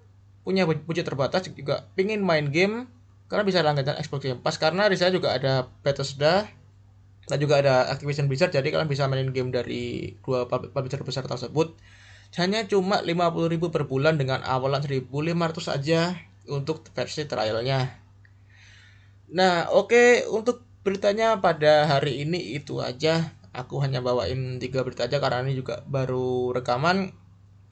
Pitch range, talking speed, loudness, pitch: 125-165 Hz, 145 wpm, -25 LUFS, 140 Hz